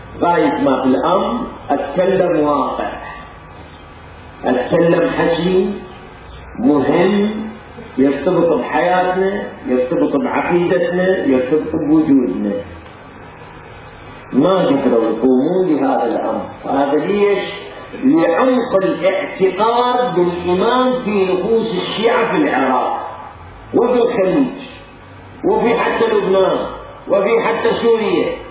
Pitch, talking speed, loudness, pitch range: 180 Hz, 80 wpm, -15 LUFS, 140-220 Hz